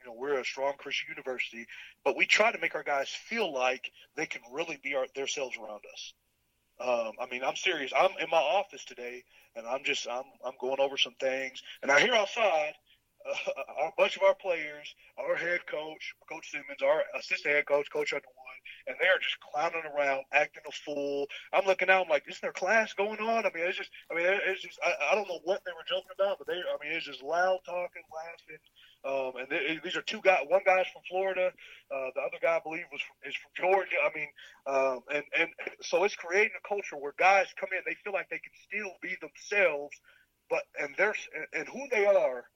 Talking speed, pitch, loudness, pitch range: 230 wpm, 170 Hz, -30 LUFS, 145-195 Hz